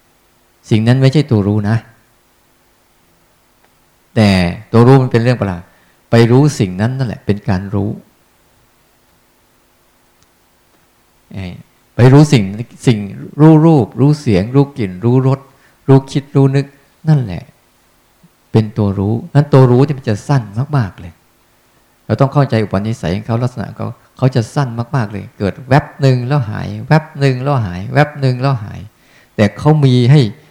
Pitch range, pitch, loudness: 100-135 Hz, 120 Hz, -13 LUFS